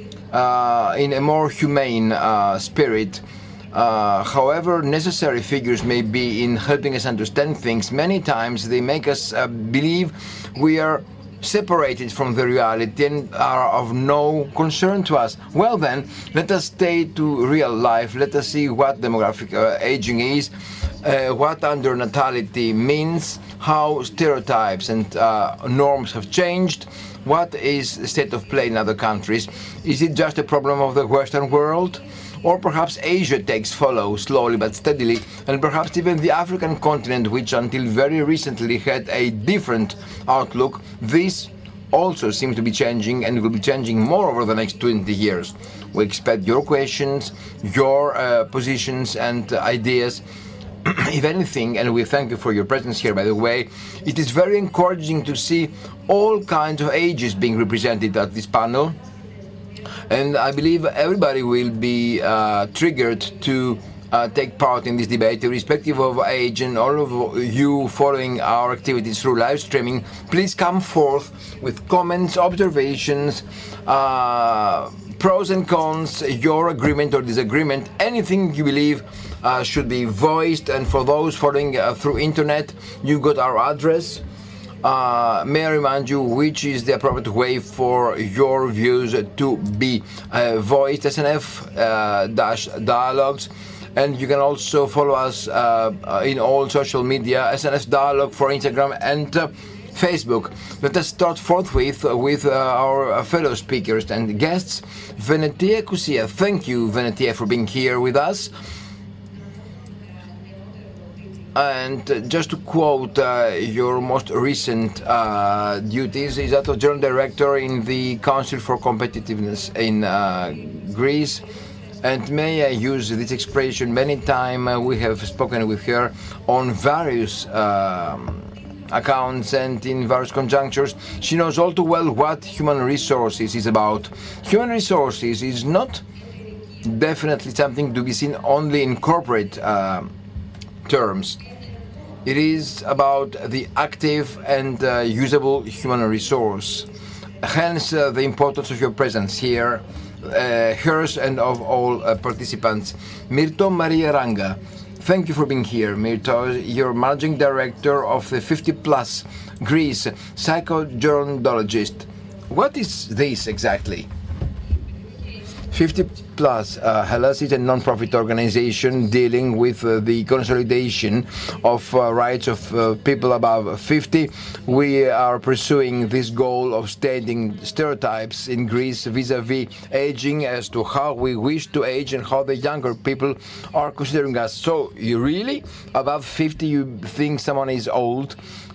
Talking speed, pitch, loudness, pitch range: 145 wpm, 125 Hz, -20 LUFS, 110-145 Hz